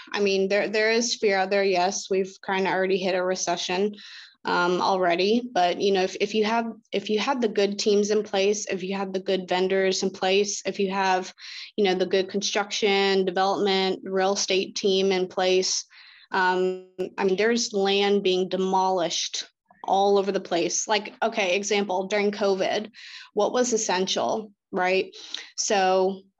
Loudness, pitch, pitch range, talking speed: -24 LUFS, 195 Hz, 185-205 Hz, 175 wpm